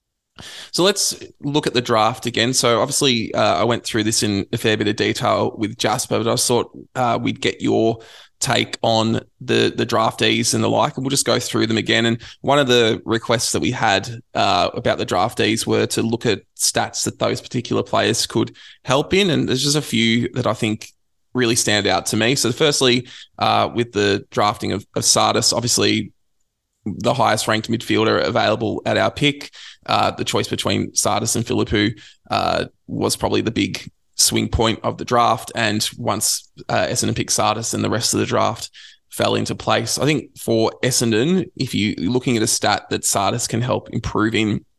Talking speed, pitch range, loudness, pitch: 195 wpm, 110-125 Hz, -19 LUFS, 115 Hz